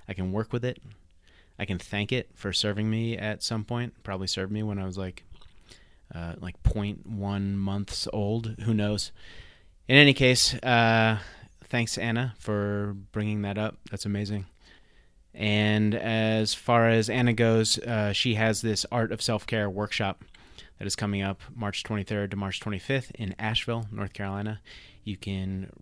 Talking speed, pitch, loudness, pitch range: 165 wpm, 105 Hz, -27 LUFS, 100-115 Hz